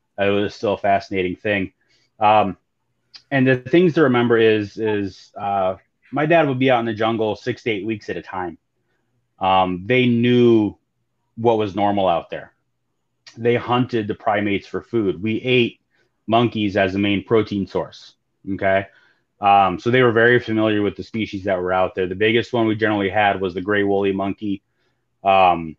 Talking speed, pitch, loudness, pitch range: 180 wpm, 105 Hz, -19 LUFS, 100-120 Hz